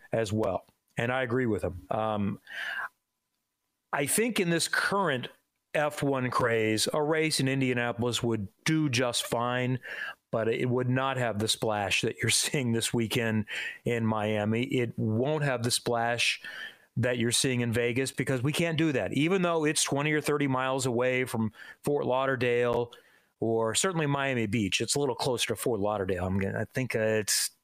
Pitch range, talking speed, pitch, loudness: 115-140 Hz, 175 wpm, 125 Hz, -28 LUFS